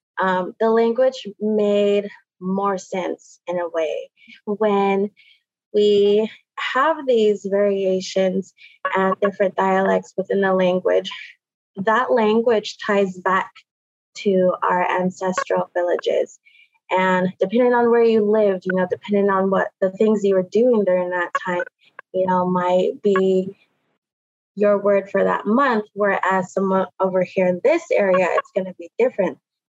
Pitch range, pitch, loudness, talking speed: 185-215 Hz, 195 Hz, -20 LUFS, 135 wpm